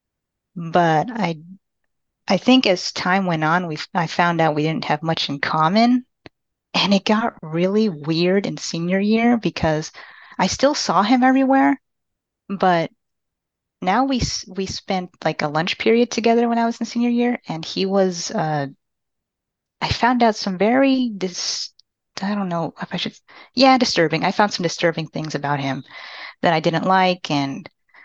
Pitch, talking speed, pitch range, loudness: 185 Hz, 165 wpm, 165-230 Hz, -19 LUFS